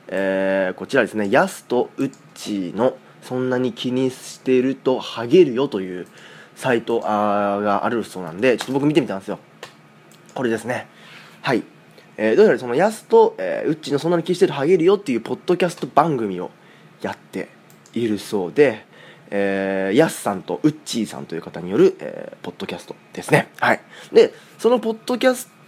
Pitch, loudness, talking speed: 130 Hz, -20 LUFS, 375 characters per minute